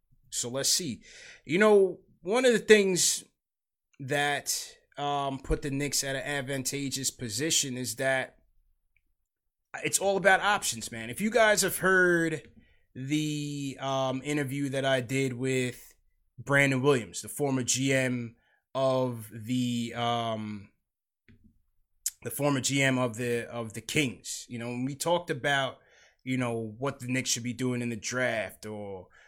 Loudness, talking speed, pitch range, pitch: -28 LUFS, 145 wpm, 120-145 Hz, 130 Hz